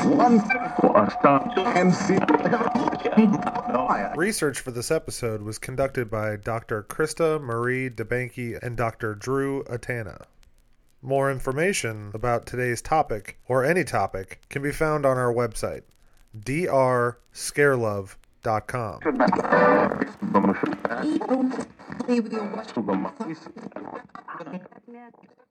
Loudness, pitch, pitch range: -24 LUFS, 135 Hz, 115-190 Hz